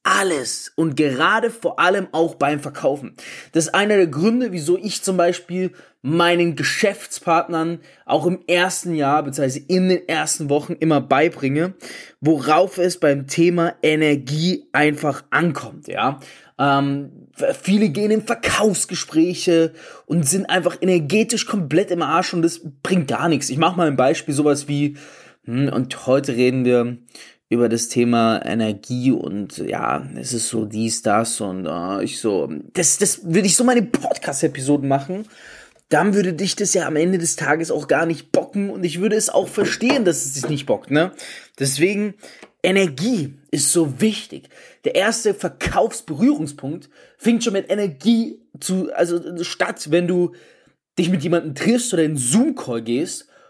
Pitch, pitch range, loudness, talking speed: 170 Hz, 145-185 Hz, -19 LUFS, 155 wpm